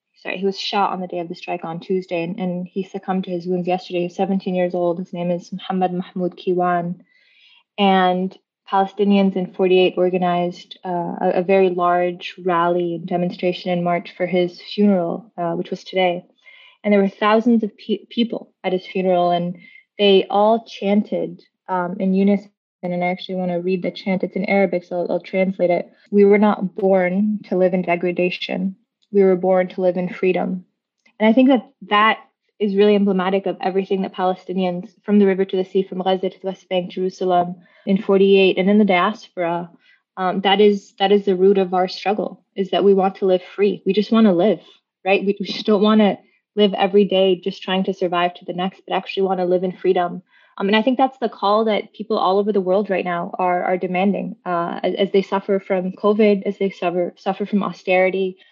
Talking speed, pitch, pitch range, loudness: 215 wpm, 190 Hz, 180-200 Hz, -19 LUFS